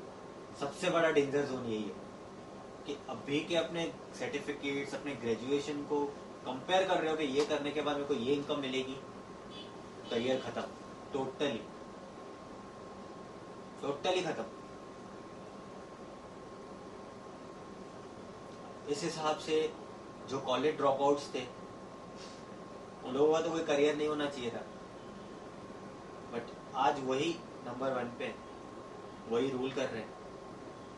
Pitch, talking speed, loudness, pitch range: 145 Hz, 120 wpm, -35 LUFS, 135-150 Hz